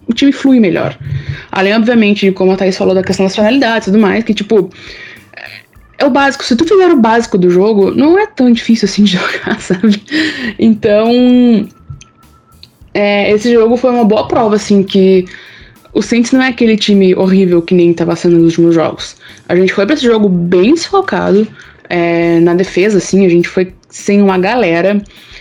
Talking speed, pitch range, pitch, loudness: 190 wpm, 185-235 Hz, 205 Hz, -10 LUFS